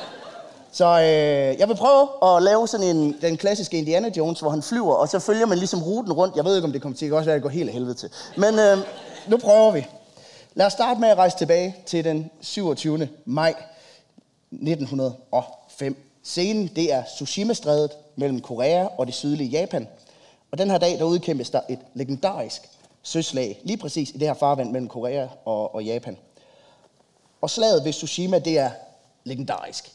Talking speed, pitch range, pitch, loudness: 185 wpm, 140-185 Hz, 160 Hz, -22 LUFS